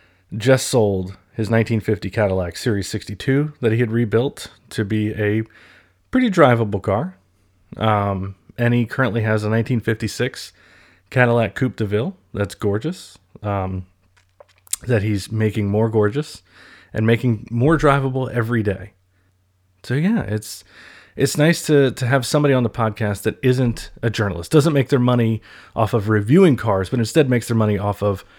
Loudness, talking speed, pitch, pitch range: -19 LUFS, 155 wpm, 110 Hz, 100-125 Hz